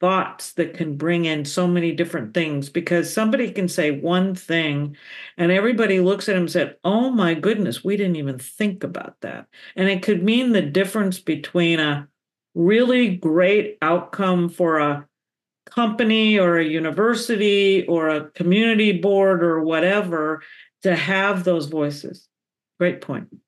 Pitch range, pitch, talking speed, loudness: 165-200 Hz, 180 Hz, 155 wpm, -20 LUFS